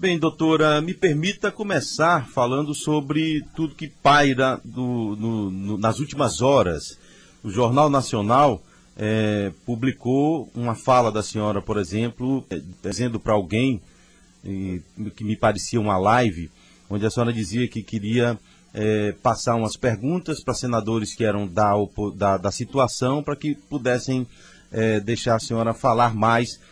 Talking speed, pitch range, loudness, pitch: 145 wpm, 105-135 Hz, -22 LUFS, 115 Hz